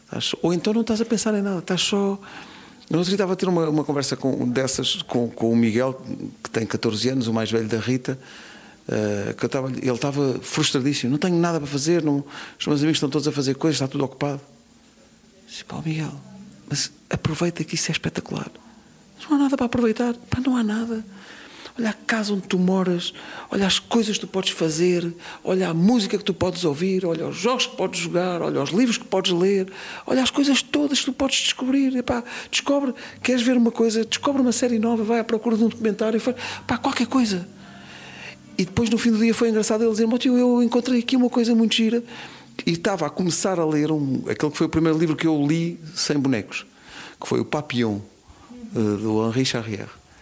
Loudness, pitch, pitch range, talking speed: -22 LUFS, 185 Hz, 145-230 Hz, 215 wpm